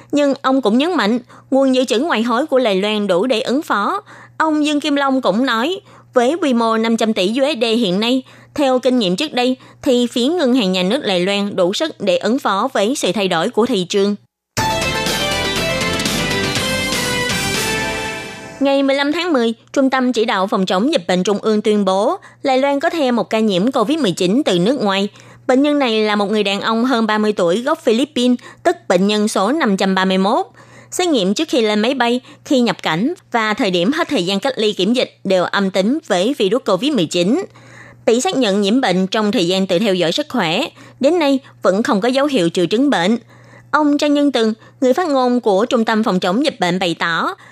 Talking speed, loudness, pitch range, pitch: 210 wpm, -16 LUFS, 200-275 Hz, 240 Hz